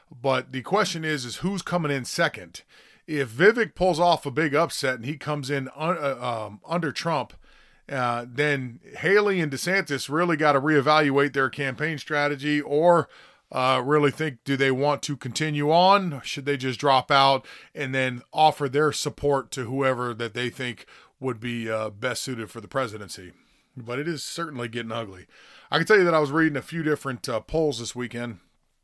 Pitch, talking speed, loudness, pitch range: 140 Hz, 190 wpm, -24 LUFS, 125-155 Hz